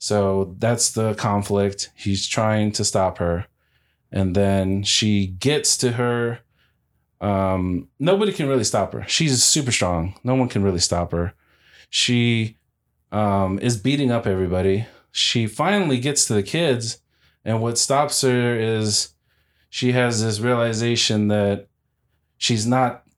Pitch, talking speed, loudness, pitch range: 110 Hz, 140 wpm, -20 LUFS, 100-125 Hz